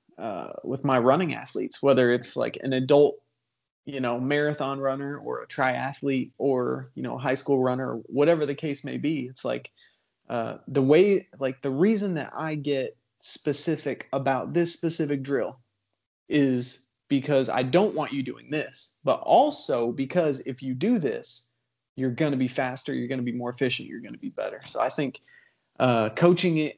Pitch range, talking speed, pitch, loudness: 125-150 Hz, 180 wpm, 135 Hz, -26 LUFS